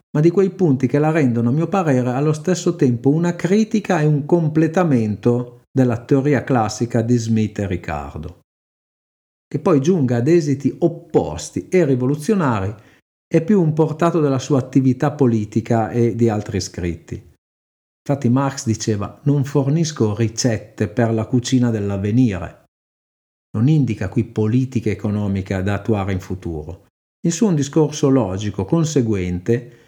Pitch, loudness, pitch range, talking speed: 125 Hz, -18 LUFS, 110-150 Hz, 140 wpm